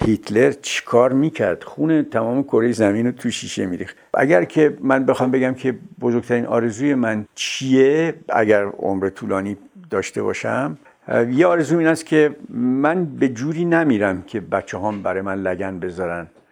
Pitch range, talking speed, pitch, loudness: 105-150 Hz, 155 wpm, 120 Hz, -19 LUFS